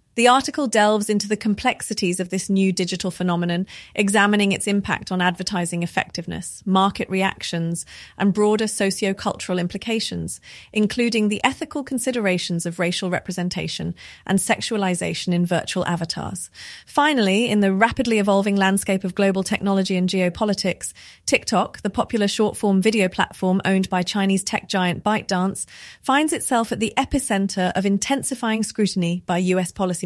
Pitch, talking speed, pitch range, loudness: 195 Hz, 140 wpm, 185-215 Hz, -21 LUFS